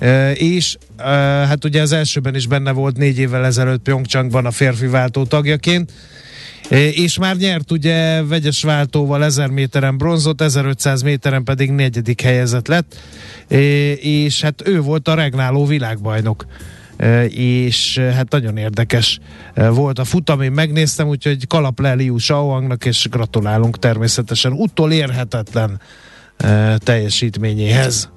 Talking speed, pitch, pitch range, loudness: 135 wpm, 135 Hz, 120-150 Hz, -15 LUFS